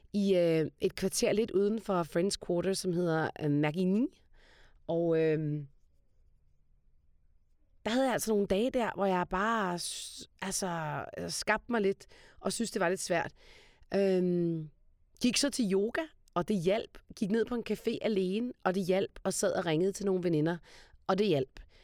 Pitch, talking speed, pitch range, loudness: 190 Hz, 170 wpm, 160-210 Hz, -32 LUFS